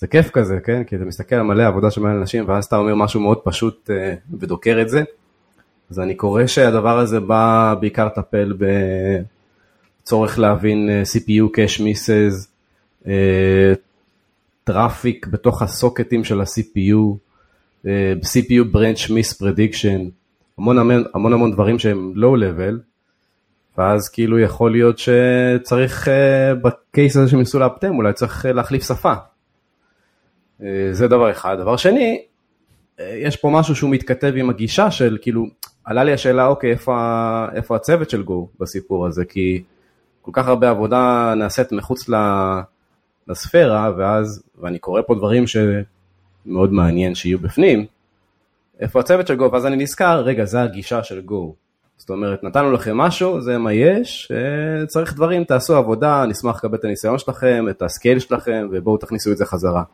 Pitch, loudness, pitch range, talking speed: 110 Hz, -17 LUFS, 100-125 Hz, 145 wpm